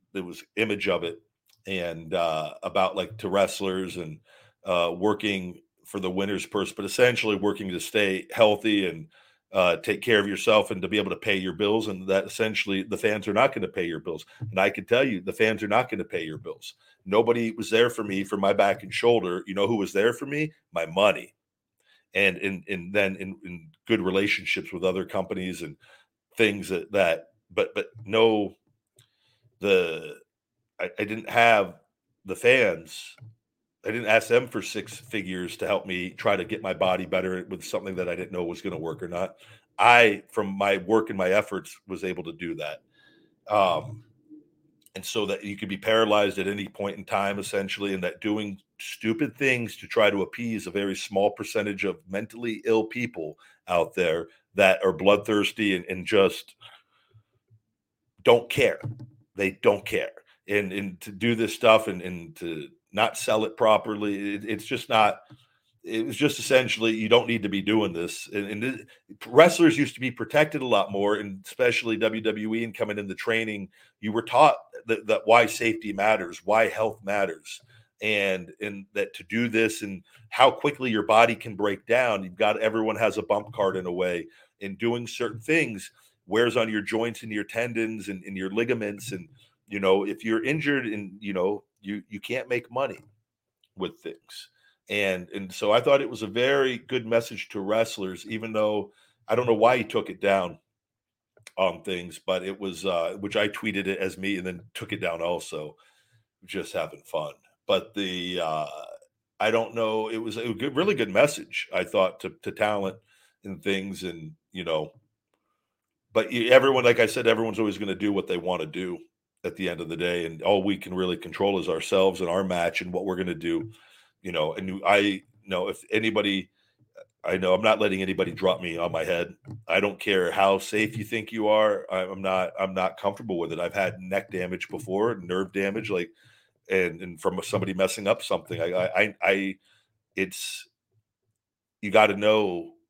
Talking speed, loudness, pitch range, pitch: 195 wpm, -25 LUFS, 95-115 Hz, 105 Hz